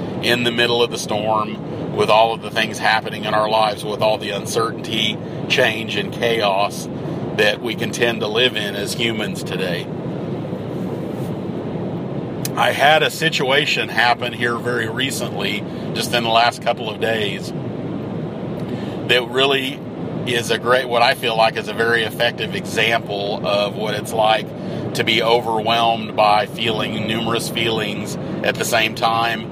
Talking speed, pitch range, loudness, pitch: 155 wpm, 110-120 Hz, -19 LUFS, 115 Hz